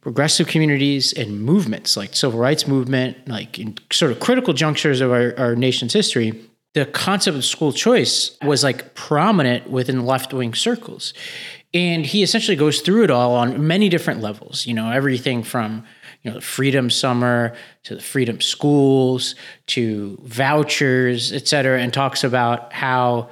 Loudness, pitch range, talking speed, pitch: -18 LUFS, 120-155 Hz, 160 wpm, 135 Hz